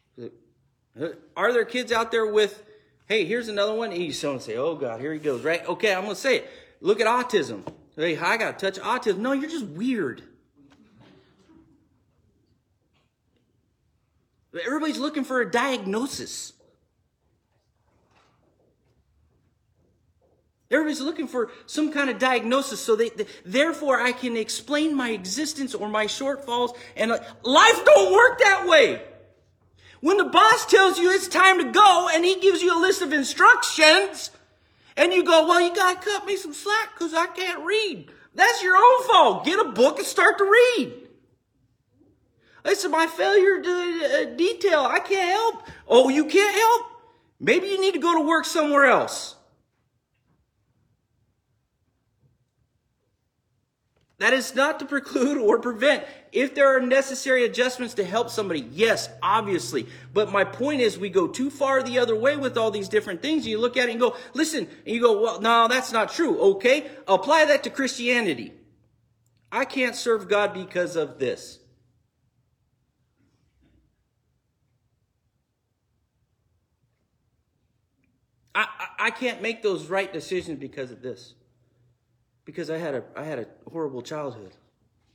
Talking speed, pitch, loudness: 150 wpm, 255 Hz, -21 LUFS